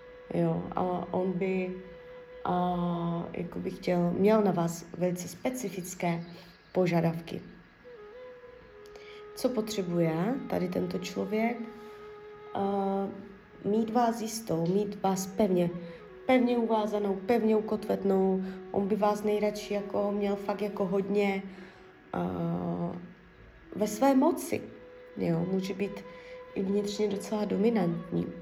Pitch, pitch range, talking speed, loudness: 200 Hz, 180-225 Hz, 105 wpm, -30 LUFS